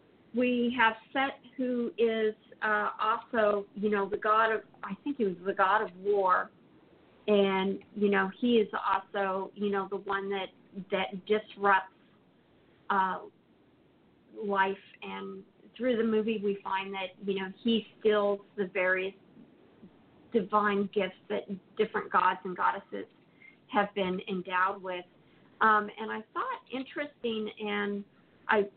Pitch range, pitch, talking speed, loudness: 195-220 Hz, 205 Hz, 135 wpm, -30 LUFS